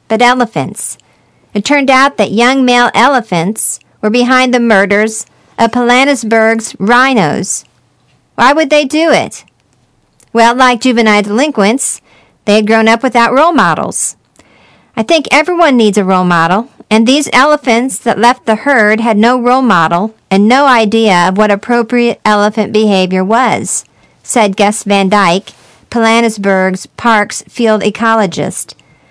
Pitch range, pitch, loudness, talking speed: 210-250 Hz, 225 Hz, -9 LUFS, 140 wpm